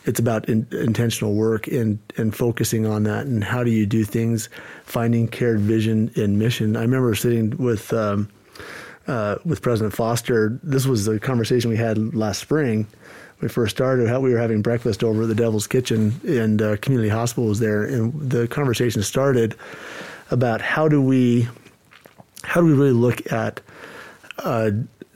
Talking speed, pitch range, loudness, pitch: 170 wpm, 110-125 Hz, -21 LUFS, 115 Hz